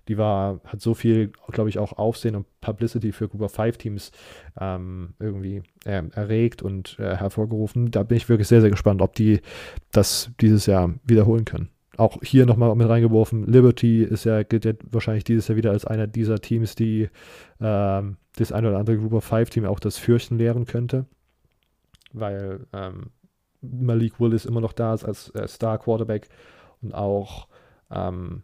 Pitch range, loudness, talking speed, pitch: 100-115 Hz, -22 LUFS, 175 wpm, 110 Hz